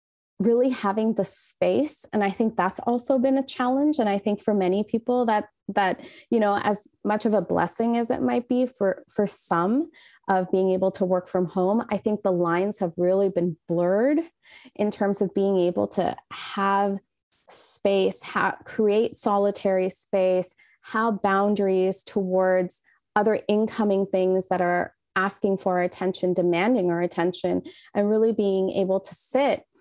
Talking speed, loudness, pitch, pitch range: 165 wpm, -24 LUFS, 200 Hz, 190-230 Hz